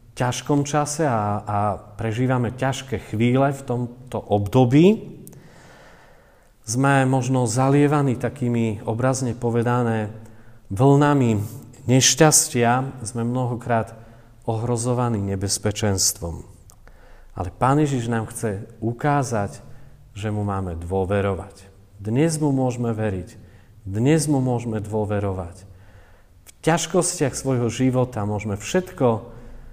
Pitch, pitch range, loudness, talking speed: 120 Hz, 105-130 Hz, -21 LUFS, 95 wpm